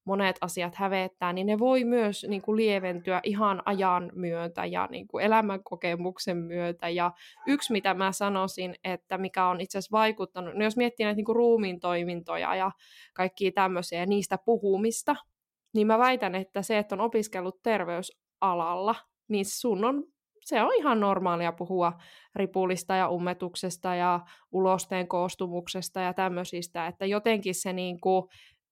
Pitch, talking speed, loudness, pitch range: 190 Hz, 150 wpm, -29 LUFS, 180-210 Hz